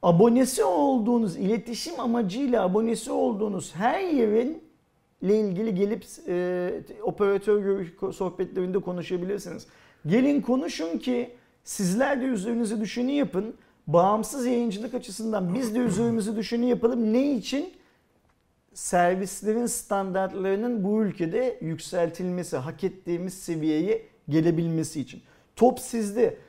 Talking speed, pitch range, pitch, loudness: 100 wpm, 185-245 Hz, 220 Hz, -26 LUFS